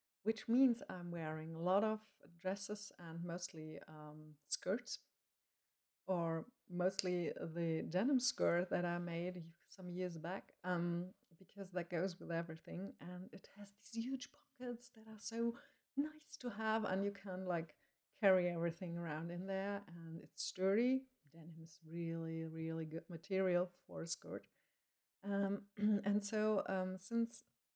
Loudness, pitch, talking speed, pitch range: -41 LUFS, 185 Hz, 145 wpm, 170-210 Hz